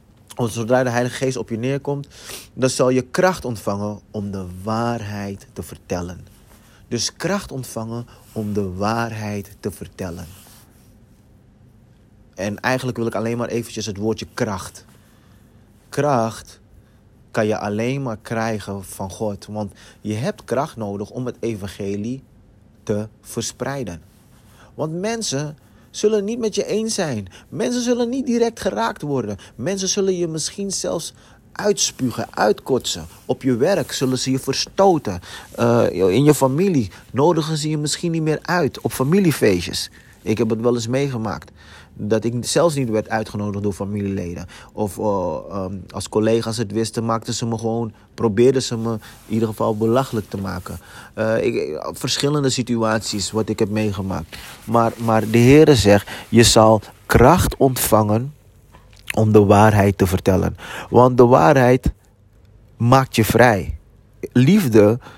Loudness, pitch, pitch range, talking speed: -19 LUFS, 115 Hz, 105-130 Hz, 145 wpm